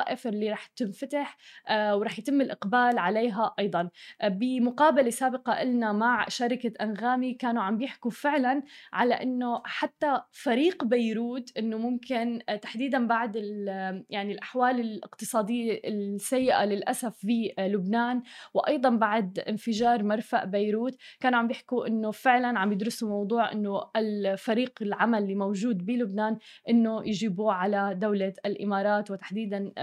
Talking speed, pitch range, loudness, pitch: 120 wpm, 210-245 Hz, -28 LUFS, 230 Hz